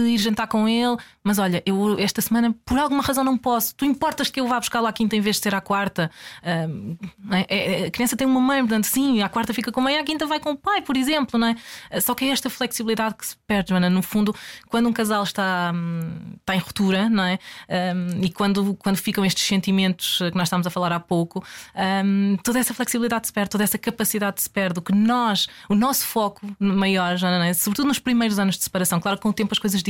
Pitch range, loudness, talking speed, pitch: 190-235 Hz, -22 LUFS, 240 wpm, 210 Hz